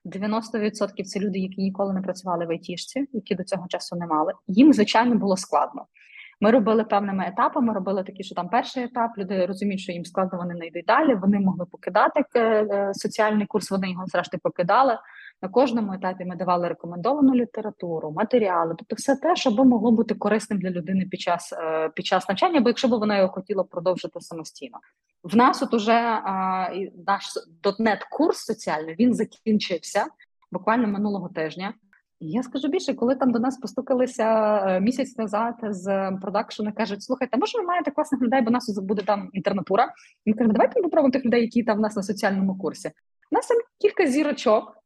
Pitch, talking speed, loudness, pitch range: 210 Hz, 185 wpm, -23 LUFS, 190-240 Hz